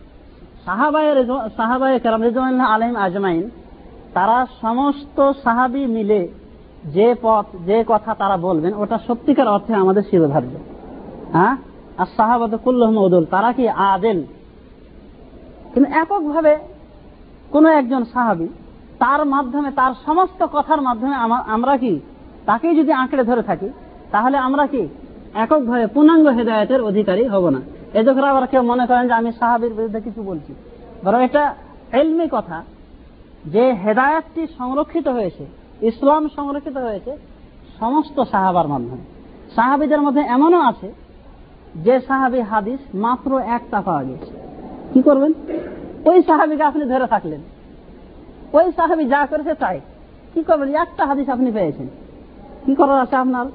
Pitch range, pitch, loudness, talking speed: 220-290 Hz, 255 Hz, -17 LUFS, 115 wpm